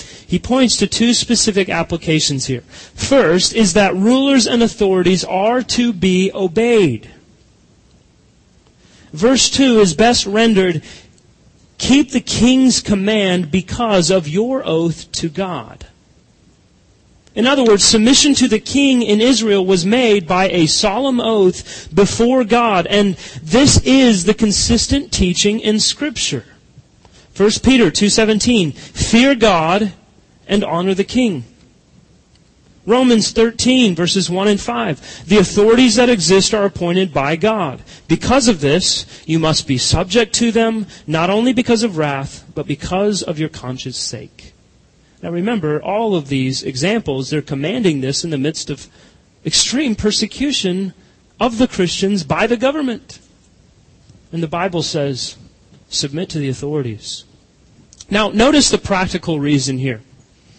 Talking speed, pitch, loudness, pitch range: 135 wpm, 195 Hz, -14 LUFS, 160-230 Hz